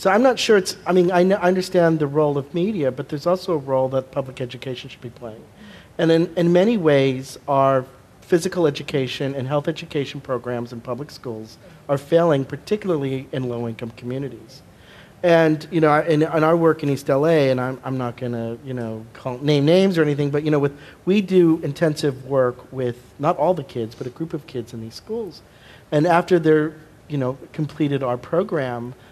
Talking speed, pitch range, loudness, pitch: 200 wpm, 130-165 Hz, -20 LUFS, 145 Hz